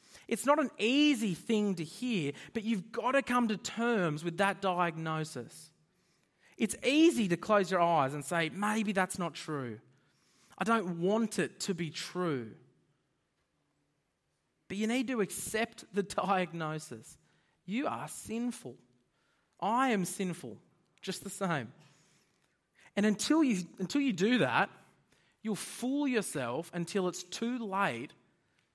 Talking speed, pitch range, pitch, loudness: 140 wpm, 170-225 Hz, 190 Hz, -32 LUFS